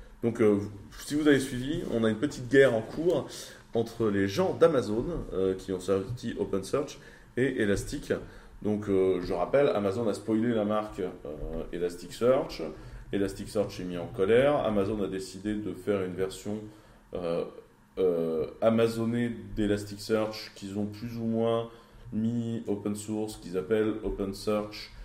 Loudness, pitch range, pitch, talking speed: -29 LUFS, 100-115 Hz, 105 Hz, 150 wpm